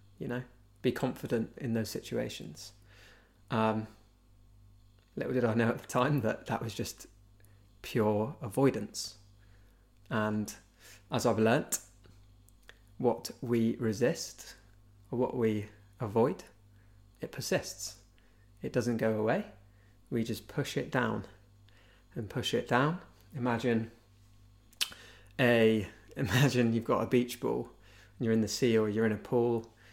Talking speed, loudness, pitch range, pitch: 130 wpm, -32 LUFS, 100-120 Hz, 110 Hz